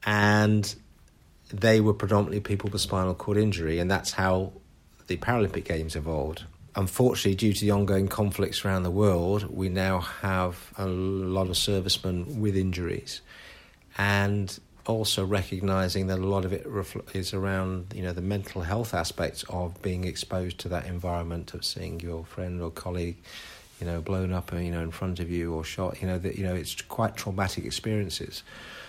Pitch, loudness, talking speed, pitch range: 95 Hz, -28 LUFS, 170 wpm, 90-100 Hz